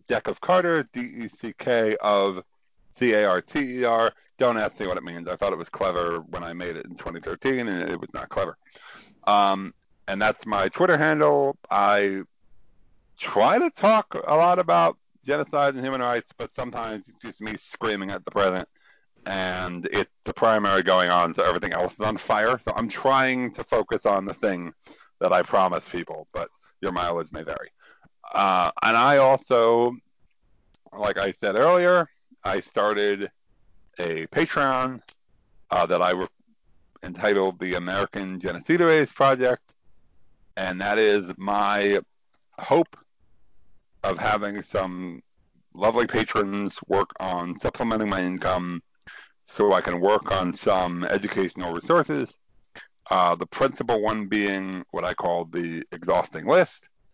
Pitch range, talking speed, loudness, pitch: 90-130 Hz, 145 wpm, -23 LUFS, 105 Hz